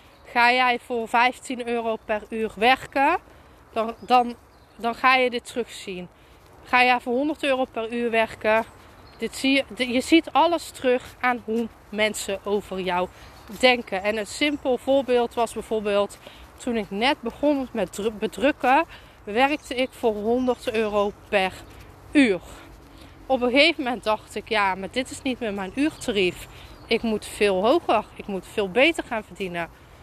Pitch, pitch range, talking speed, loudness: 235 Hz, 210-260 Hz, 160 wpm, -23 LUFS